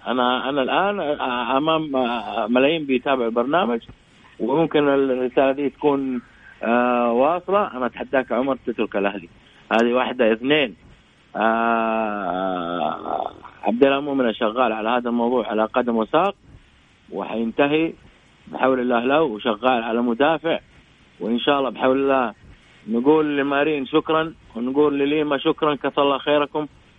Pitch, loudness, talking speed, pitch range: 130 Hz, -21 LUFS, 115 wpm, 120-145 Hz